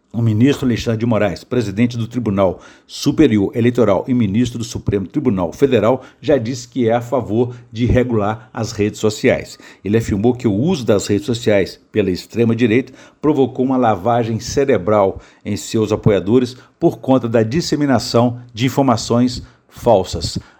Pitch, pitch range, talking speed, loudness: 120 Hz, 110-130 Hz, 150 wpm, -17 LUFS